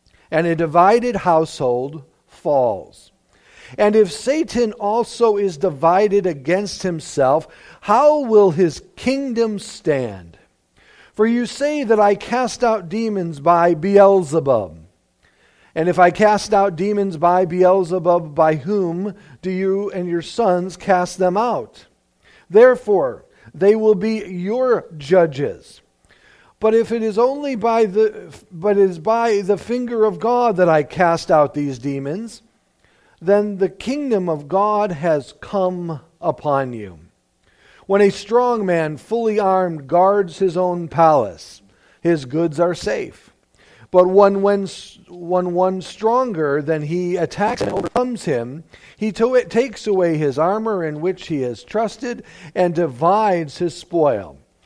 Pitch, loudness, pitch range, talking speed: 190 Hz, -18 LUFS, 165-220 Hz, 135 wpm